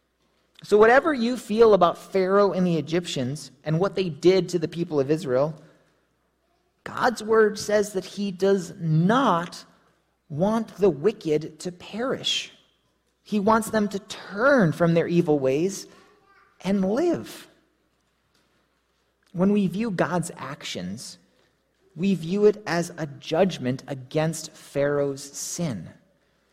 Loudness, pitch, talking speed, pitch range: -23 LUFS, 185 Hz, 125 wpm, 160-210 Hz